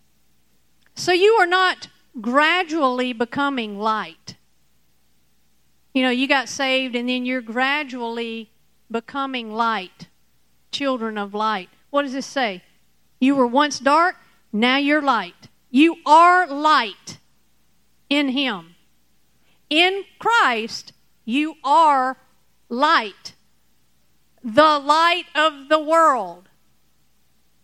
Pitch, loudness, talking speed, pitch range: 270 Hz, -19 LUFS, 100 wpm, 235-305 Hz